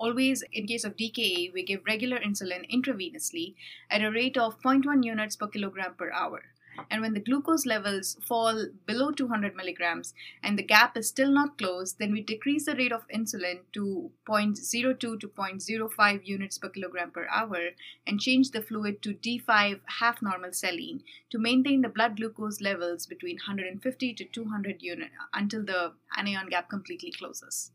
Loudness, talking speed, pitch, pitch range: -29 LUFS, 170 wpm, 215 Hz, 195-250 Hz